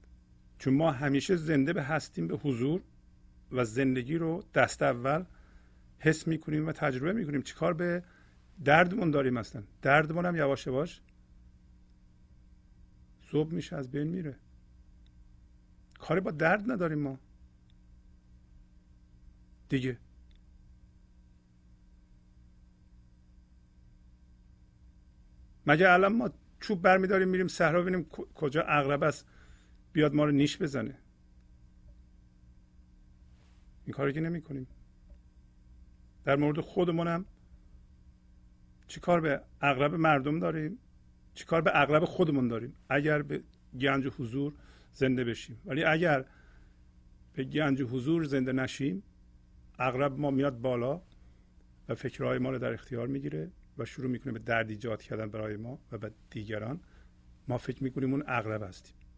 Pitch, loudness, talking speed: 110 Hz, -30 LUFS, 120 wpm